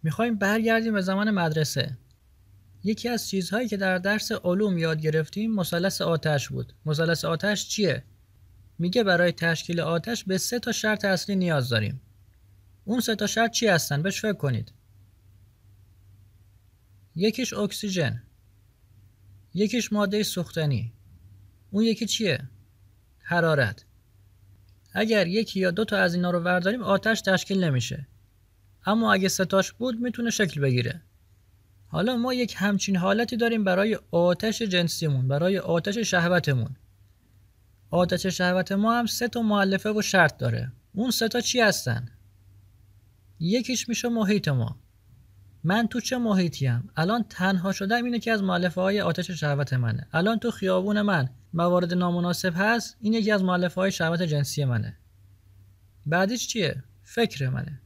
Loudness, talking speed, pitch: -25 LUFS, 140 wpm, 175 Hz